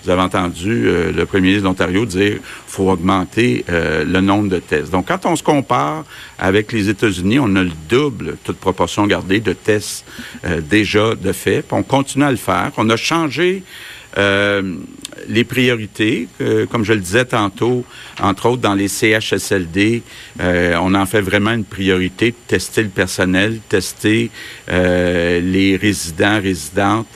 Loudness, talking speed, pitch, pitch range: -16 LUFS, 170 wpm, 100 Hz, 95-115 Hz